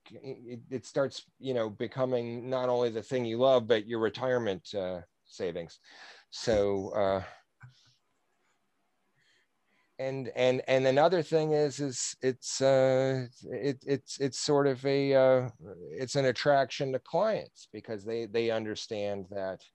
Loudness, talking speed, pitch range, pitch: -30 LUFS, 135 wpm, 115-135 Hz, 130 Hz